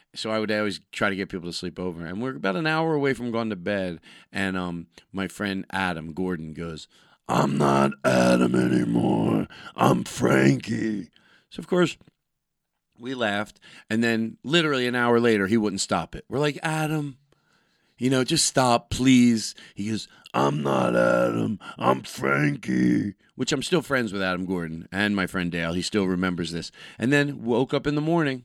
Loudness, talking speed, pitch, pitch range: -24 LUFS, 180 wpm, 100 Hz, 85-125 Hz